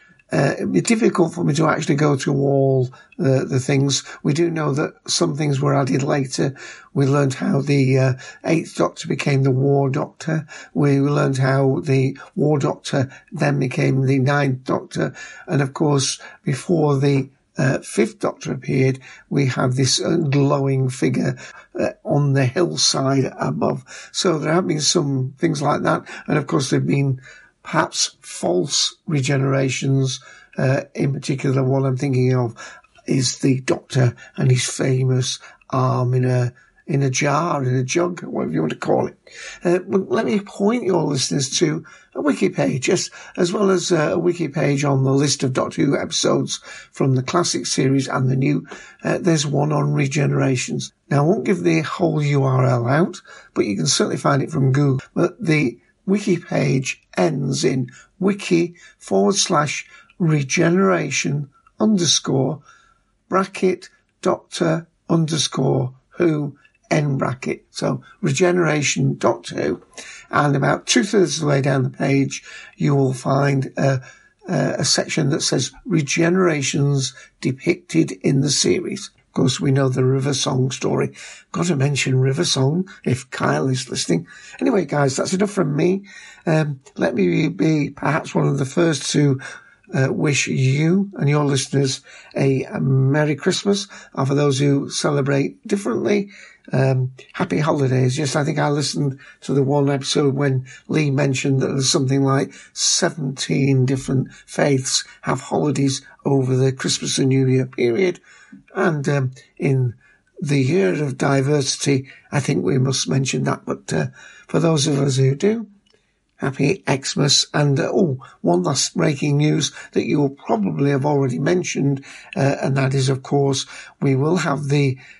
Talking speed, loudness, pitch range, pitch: 160 wpm, -20 LUFS, 135-165 Hz, 140 Hz